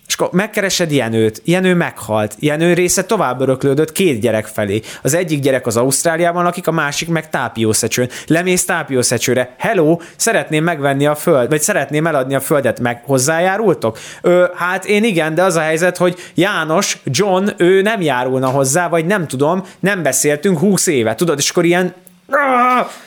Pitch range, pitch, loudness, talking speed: 135-180 Hz, 165 Hz, -15 LUFS, 165 wpm